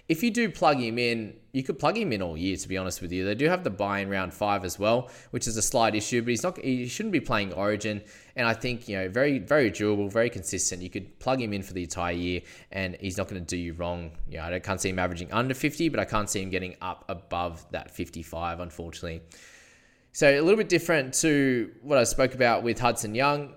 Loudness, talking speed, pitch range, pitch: -27 LUFS, 255 wpm, 90-125 Hz, 105 Hz